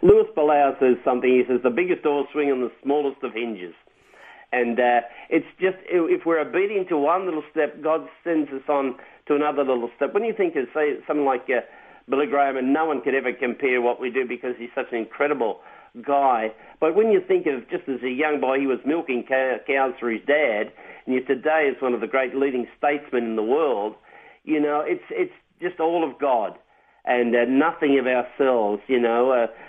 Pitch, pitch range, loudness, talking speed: 135 Hz, 125-155 Hz, -23 LUFS, 215 wpm